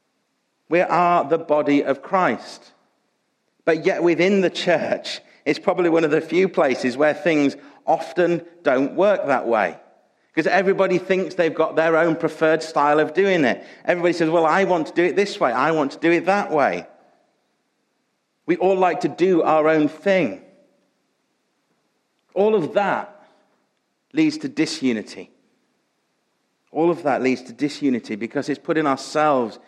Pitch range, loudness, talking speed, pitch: 150-185 Hz, -20 LUFS, 160 wpm, 165 Hz